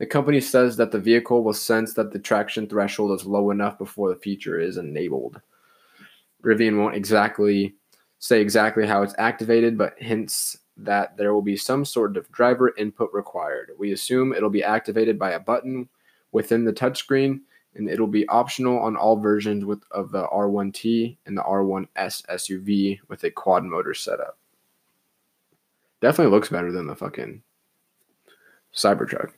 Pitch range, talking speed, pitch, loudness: 100-120 Hz, 160 wpm, 110 Hz, -23 LUFS